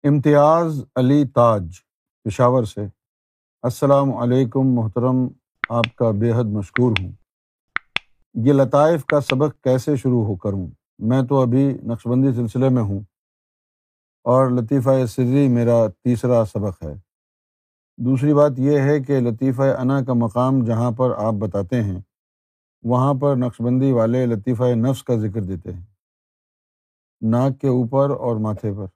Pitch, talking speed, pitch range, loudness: 125 Hz, 135 wpm, 110-135 Hz, -19 LUFS